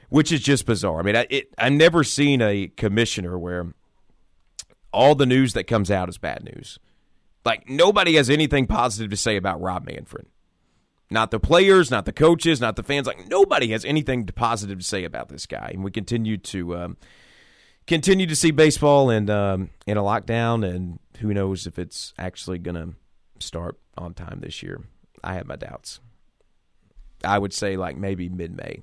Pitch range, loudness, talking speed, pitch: 95-140 Hz, -21 LUFS, 185 wpm, 110 Hz